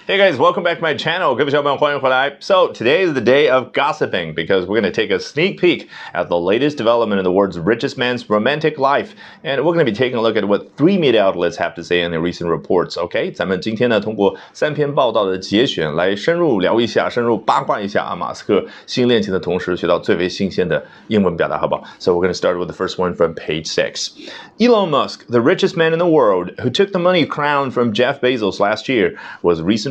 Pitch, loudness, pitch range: 125 Hz, -17 LUFS, 100-155 Hz